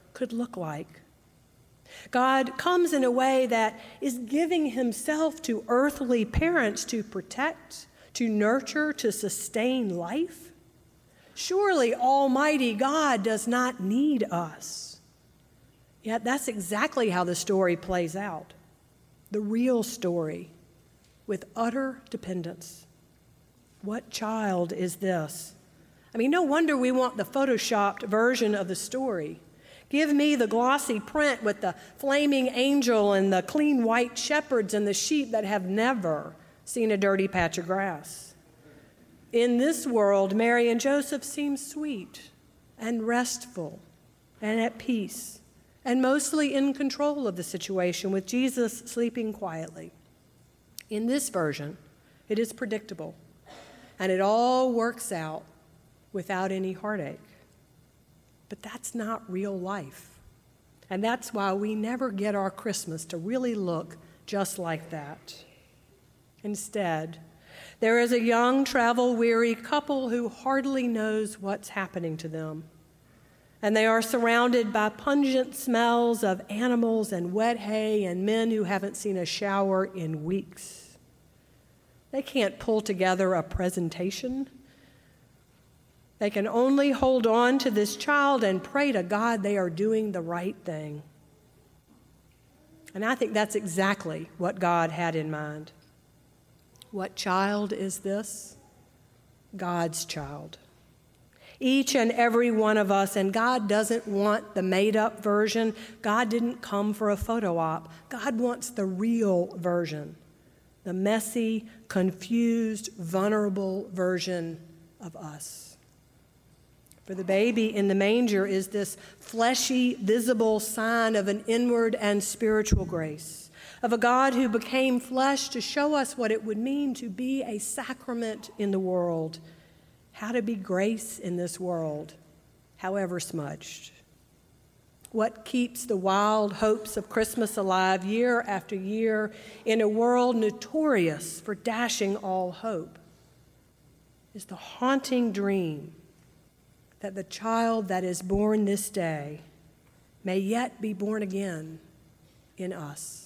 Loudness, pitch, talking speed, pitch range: -27 LUFS, 210 Hz, 130 wpm, 185-240 Hz